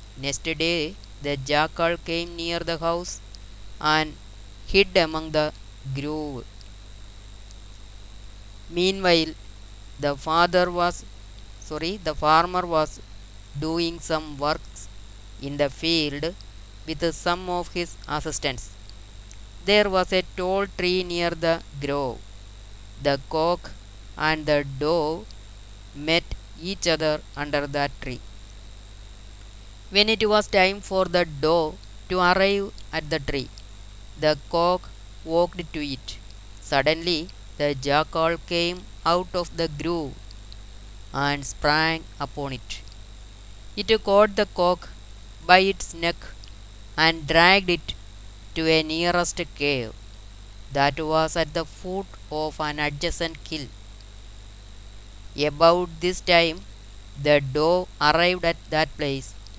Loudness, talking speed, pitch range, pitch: -23 LUFS, 115 wpm, 105-170 Hz, 150 Hz